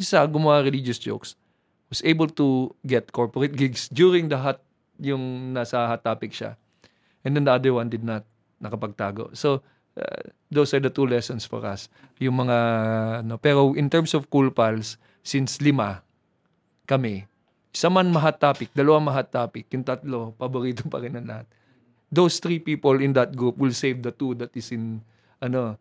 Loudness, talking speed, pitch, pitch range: -23 LUFS, 175 wpm, 130 Hz, 115-140 Hz